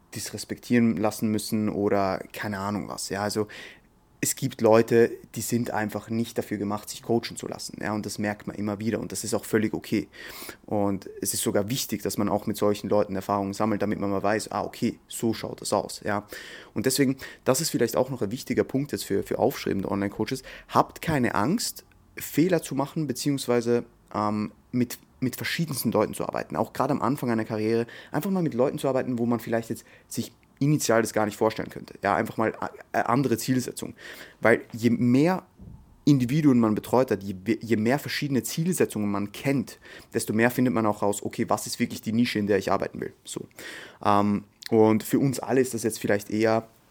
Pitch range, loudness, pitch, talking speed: 105-125 Hz, -26 LUFS, 115 Hz, 200 wpm